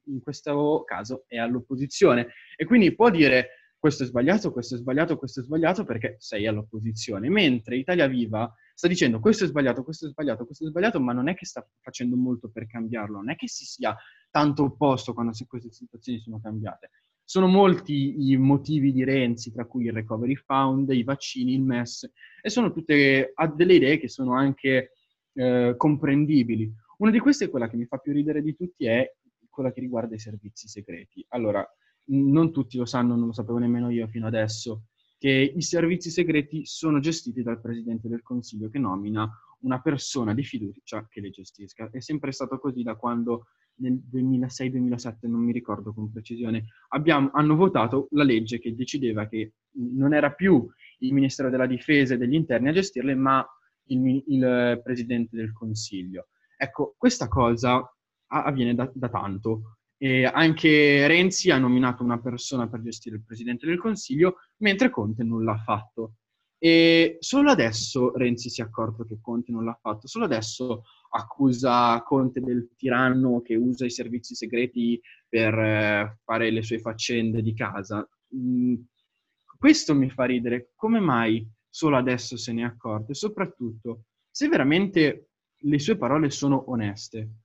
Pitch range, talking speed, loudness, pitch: 115-145 Hz, 170 wpm, -24 LUFS, 125 Hz